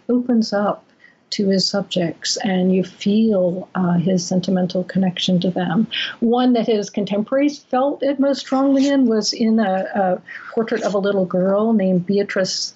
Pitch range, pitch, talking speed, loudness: 185-235 Hz, 200 Hz, 160 wpm, -19 LUFS